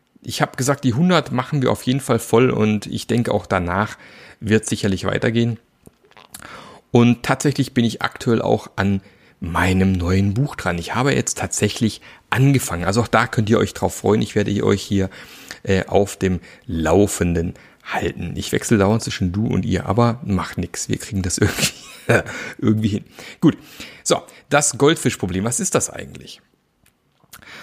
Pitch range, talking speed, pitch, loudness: 95-120 Hz, 165 wpm, 105 Hz, -19 LUFS